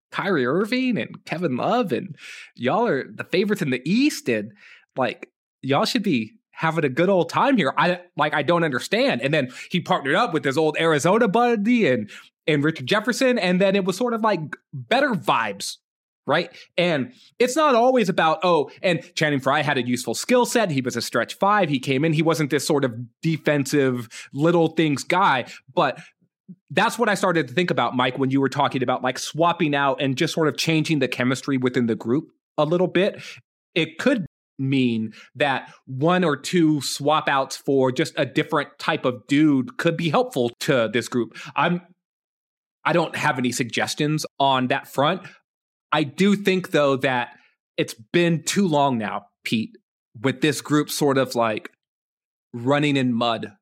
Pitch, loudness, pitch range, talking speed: 155 Hz, -22 LUFS, 135-180 Hz, 185 wpm